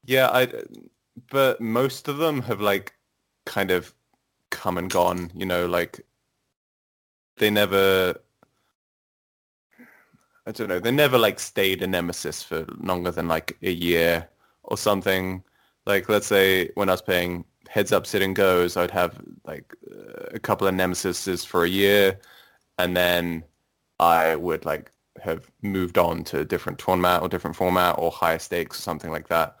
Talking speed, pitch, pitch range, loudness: 160 wpm, 95 Hz, 90-105 Hz, -23 LUFS